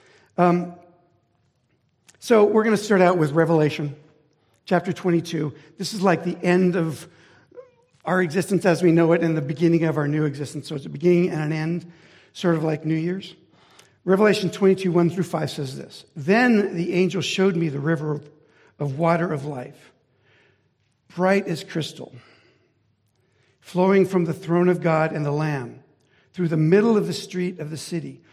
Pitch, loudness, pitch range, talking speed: 170 Hz, -22 LUFS, 150-185 Hz, 170 wpm